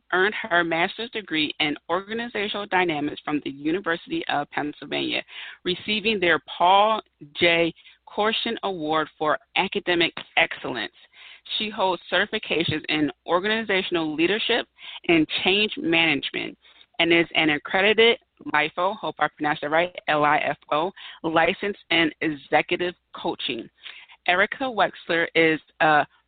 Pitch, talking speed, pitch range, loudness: 175 Hz, 120 wpm, 155-215 Hz, -23 LUFS